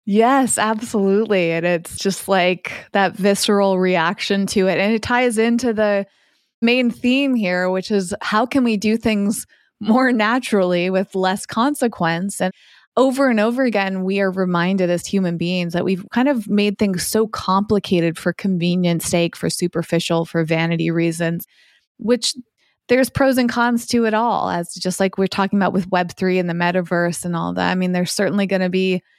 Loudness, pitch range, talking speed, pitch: -18 LUFS, 180-225 Hz, 180 wpm, 195 Hz